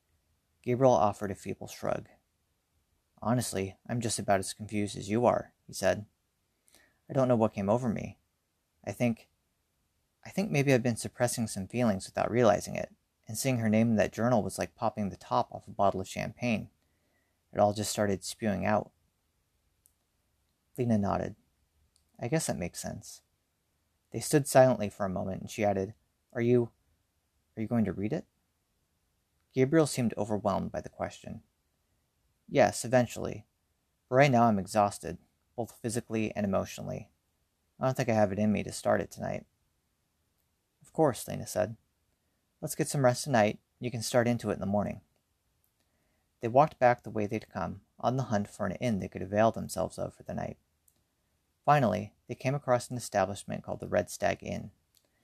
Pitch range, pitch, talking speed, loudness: 85-120 Hz, 105 Hz, 175 wpm, -30 LUFS